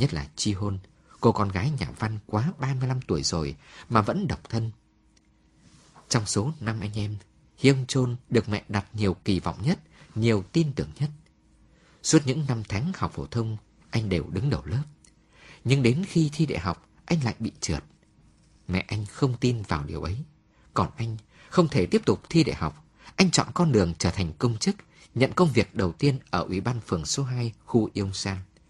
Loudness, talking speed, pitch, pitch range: -27 LUFS, 200 wpm, 115 Hz, 100-140 Hz